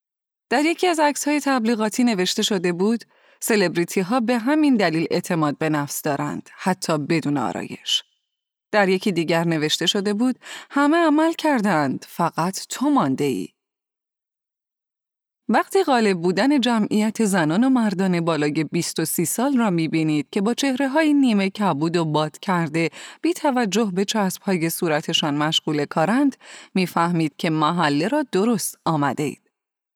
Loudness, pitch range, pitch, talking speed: -21 LUFS, 165-245 Hz, 195 Hz, 145 wpm